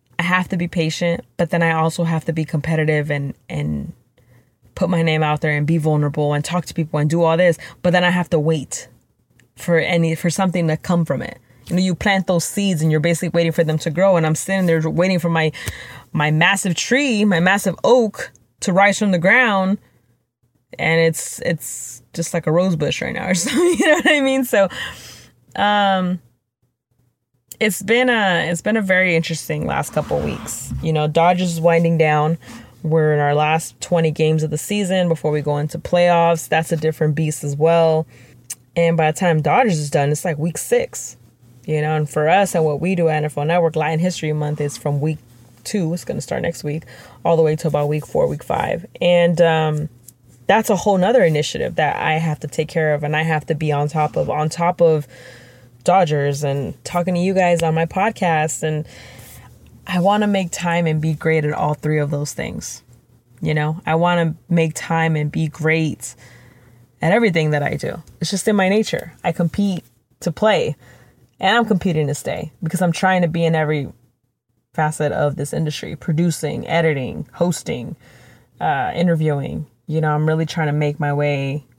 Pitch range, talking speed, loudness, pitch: 150-175 Hz, 205 wpm, -18 LUFS, 160 Hz